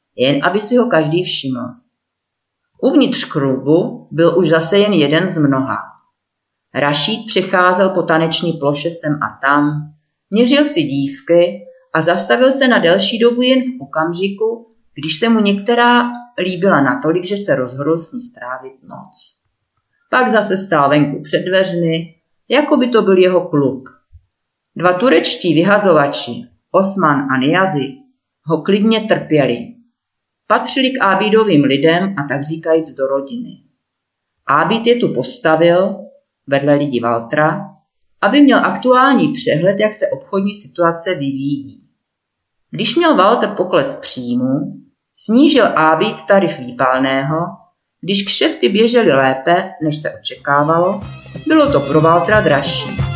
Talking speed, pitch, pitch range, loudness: 130 wpm, 175 Hz, 145-225 Hz, -14 LUFS